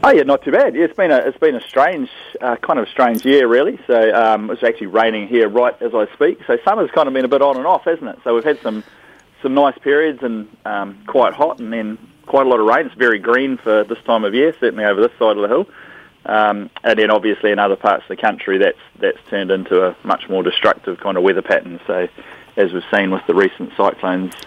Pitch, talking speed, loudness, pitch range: 115 Hz, 260 wpm, -16 LUFS, 105-140 Hz